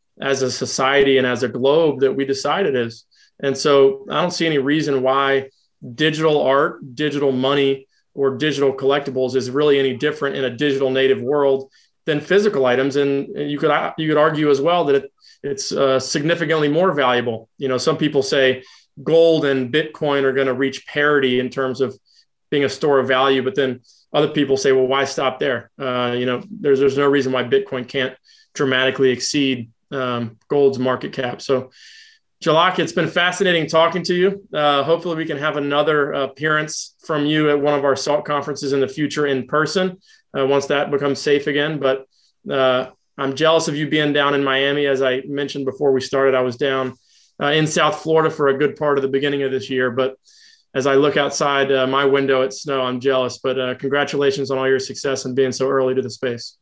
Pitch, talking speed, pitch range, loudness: 140 Hz, 205 wpm, 130-150 Hz, -18 LUFS